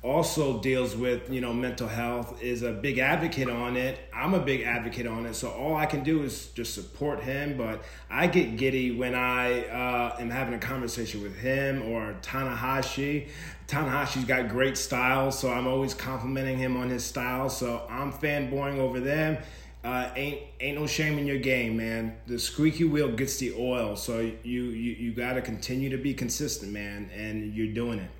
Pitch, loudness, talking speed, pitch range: 125 Hz, -29 LUFS, 190 wpm, 120-135 Hz